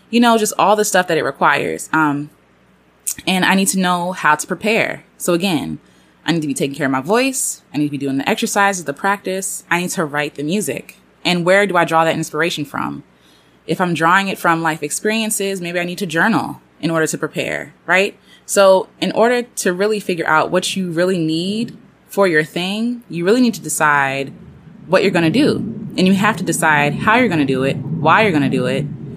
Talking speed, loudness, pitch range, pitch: 225 wpm, -16 LUFS, 155-200 Hz, 175 Hz